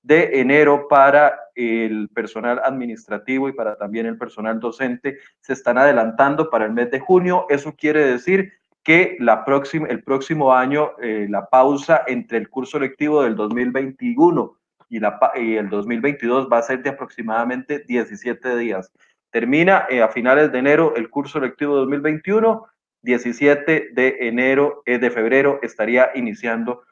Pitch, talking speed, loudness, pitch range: 130 Hz, 150 wpm, -18 LUFS, 115-145 Hz